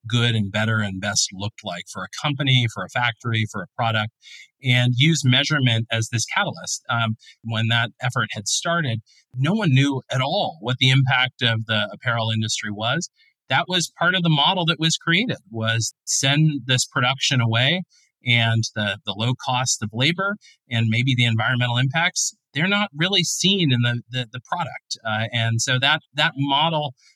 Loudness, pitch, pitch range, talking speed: -21 LUFS, 125 Hz, 115-150 Hz, 180 wpm